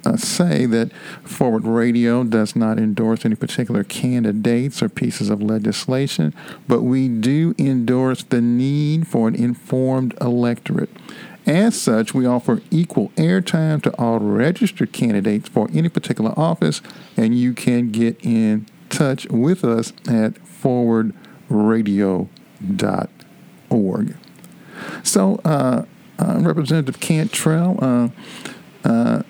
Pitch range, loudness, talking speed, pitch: 115-165 Hz, -19 LUFS, 115 wpm, 125 Hz